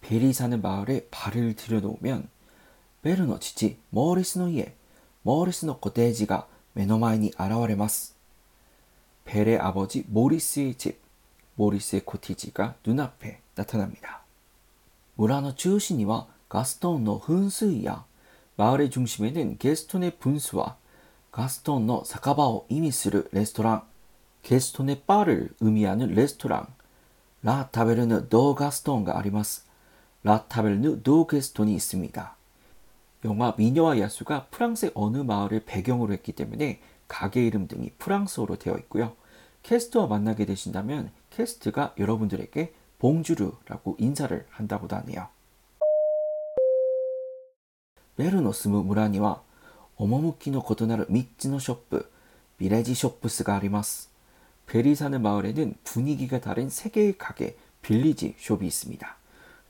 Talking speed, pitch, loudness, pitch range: 300 characters per minute, 115 Hz, -26 LUFS, 105-145 Hz